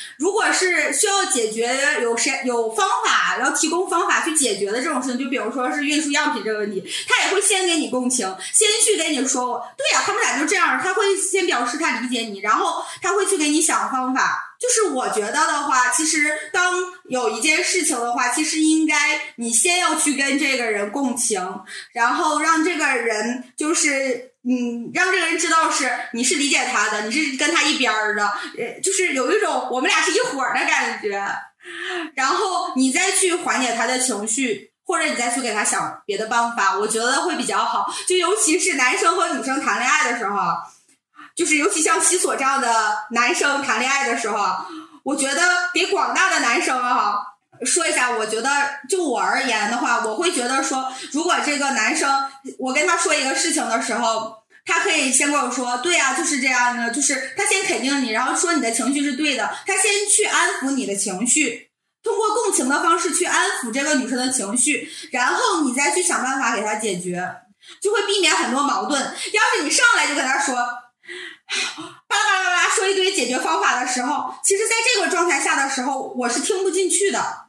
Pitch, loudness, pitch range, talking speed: 290 Hz, -19 LUFS, 250-355 Hz, 295 characters per minute